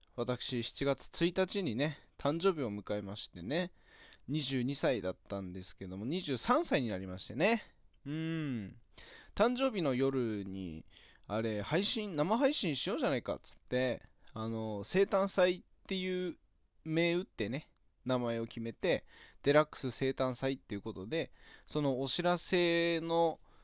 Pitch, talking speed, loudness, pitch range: 135 Hz, 260 characters per minute, -35 LUFS, 115-175 Hz